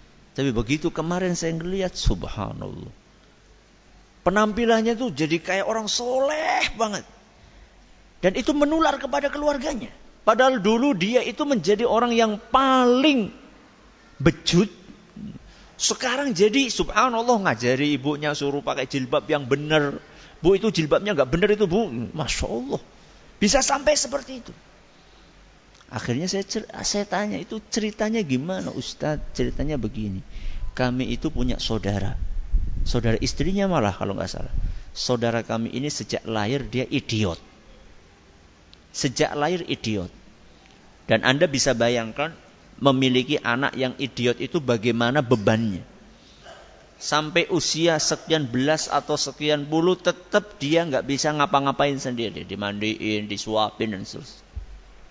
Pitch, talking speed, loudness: 150 Hz, 120 wpm, -23 LUFS